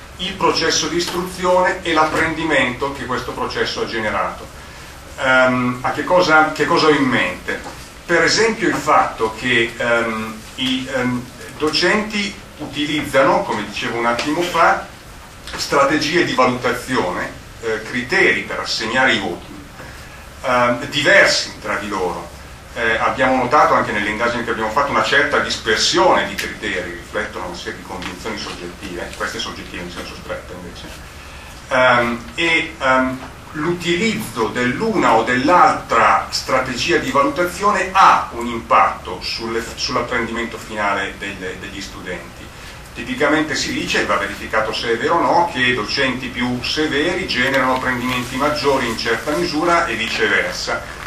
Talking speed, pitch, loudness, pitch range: 135 wpm, 125 Hz, -17 LUFS, 110-150 Hz